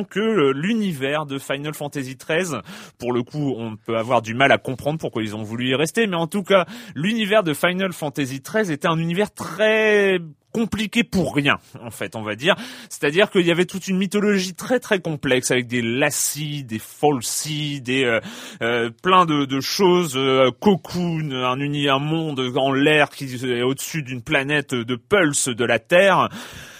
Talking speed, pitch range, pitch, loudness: 185 wpm, 130-185 Hz, 150 Hz, -20 LUFS